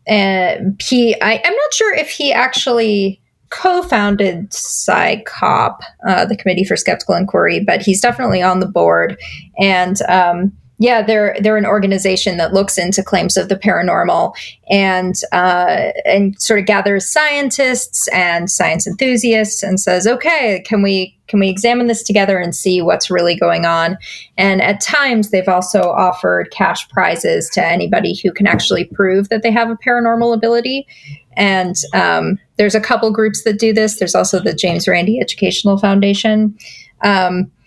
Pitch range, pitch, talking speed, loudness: 185-230 Hz, 200 Hz, 165 wpm, -13 LUFS